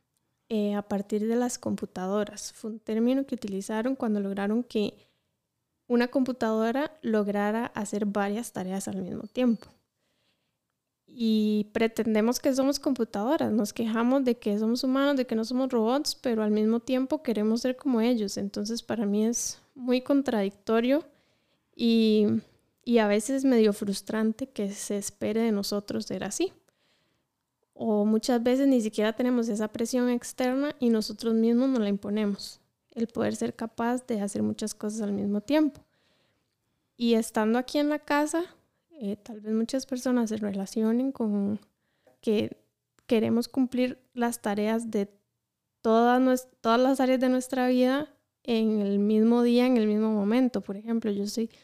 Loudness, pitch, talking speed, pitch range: -27 LUFS, 230 Hz, 150 wpm, 215-255 Hz